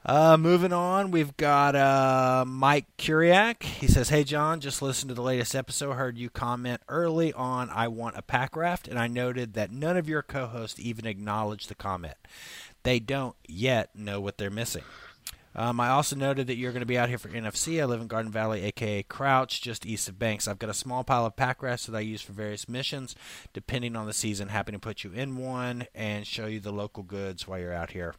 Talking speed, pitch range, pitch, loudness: 225 wpm, 105-135 Hz, 120 Hz, -28 LUFS